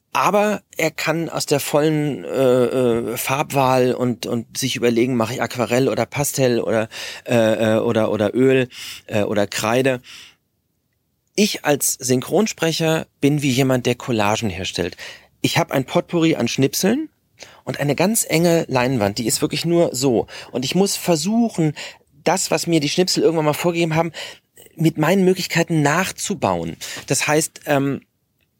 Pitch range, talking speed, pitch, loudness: 120-165 Hz, 150 wpm, 140 Hz, -19 LUFS